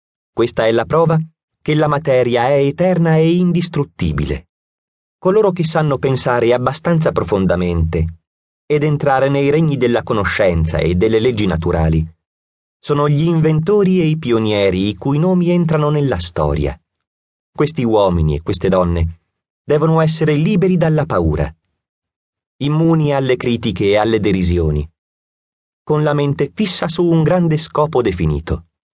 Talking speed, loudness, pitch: 135 wpm, -15 LUFS, 125 Hz